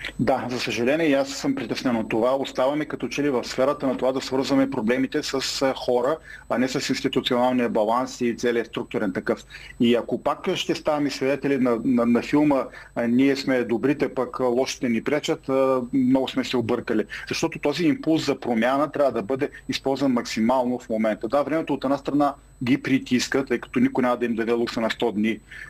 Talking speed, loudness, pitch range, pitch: 195 wpm, -23 LUFS, 120-140 Hz, 130 Hz